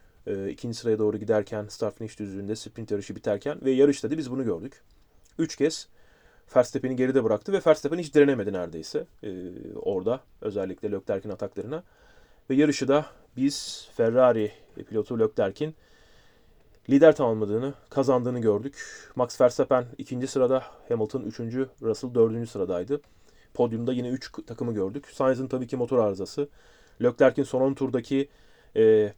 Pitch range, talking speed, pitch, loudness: 110-135 Hz, 140 wpm, 125 Hz, -26 LUFS